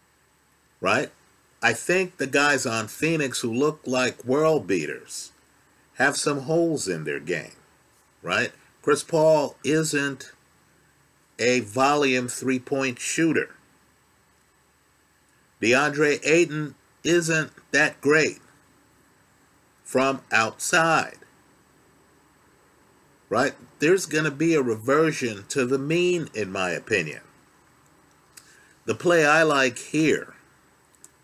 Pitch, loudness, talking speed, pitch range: 140 Hz, -23 LUFS, 100 wpm, 125-155 Hz